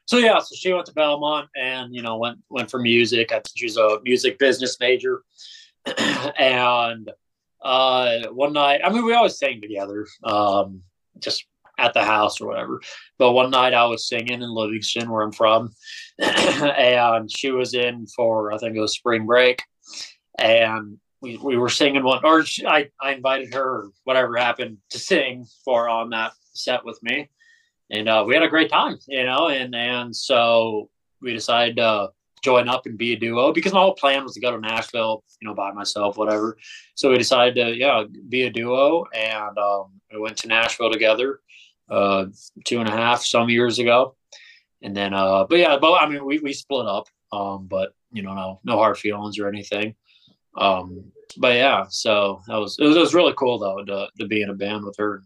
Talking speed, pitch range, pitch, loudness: 200 wpm, 105-135 Hz, 120 Hz, -20 LUFS